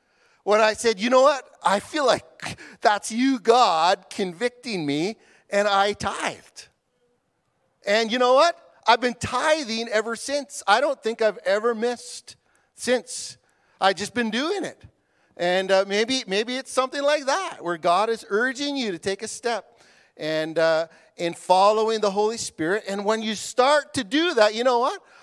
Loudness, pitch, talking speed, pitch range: -23 LUFS, 225 Hz, 170 wpm, 200-255 Hz